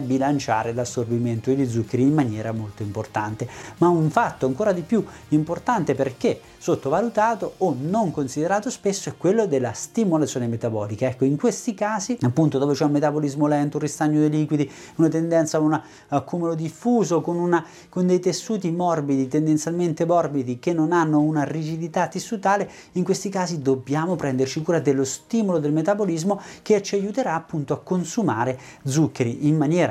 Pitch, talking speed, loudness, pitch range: 155 Hz, 160 wpm, -23 LUFS, 135-180 Hz